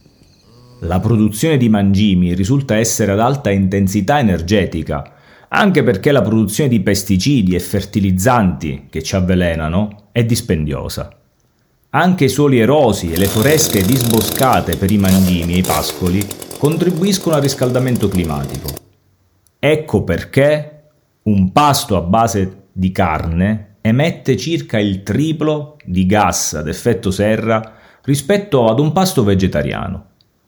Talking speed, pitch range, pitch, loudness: 125 wpm, 95-130 Hz, 105 Hz, -15 LUFS